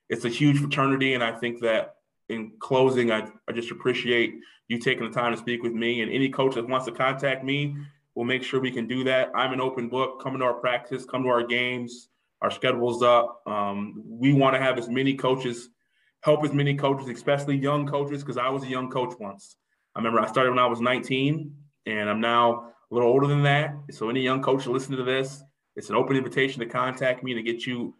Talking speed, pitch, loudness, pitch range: 230 wpm, 130 Hz, -25 LUFS, 120-135 Hz